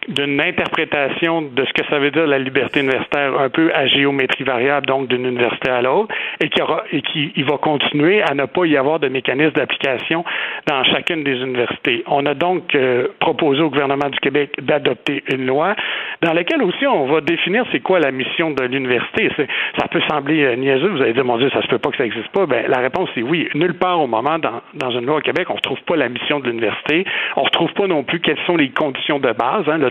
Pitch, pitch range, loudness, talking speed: 145 Hz, 135-155 Hz, -17 LUFS, 240 wpm